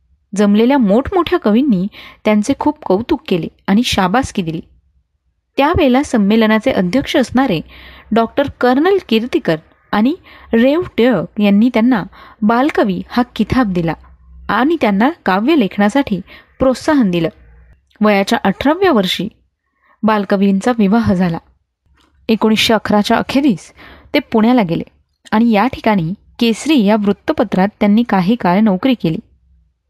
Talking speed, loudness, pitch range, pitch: 110 wpm, -14 LUFS, 195-260 Hz, 220 Hz